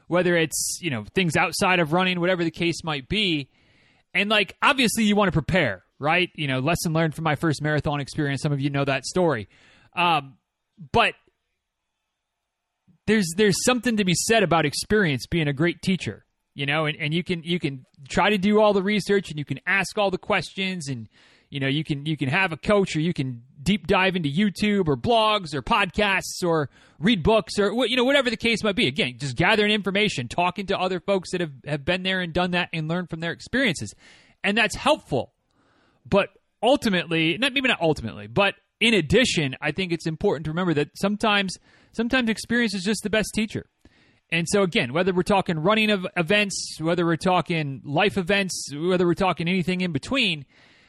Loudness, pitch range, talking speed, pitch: -23 LUFS, 155-205 Hz, 205 wpm, 180 Hz